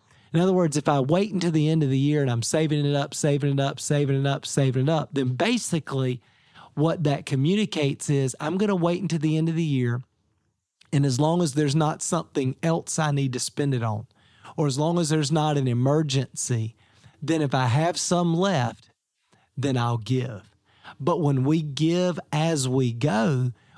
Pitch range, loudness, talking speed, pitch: 130-160 Hz, -24 LUFS, 200 wpm, 145 Hz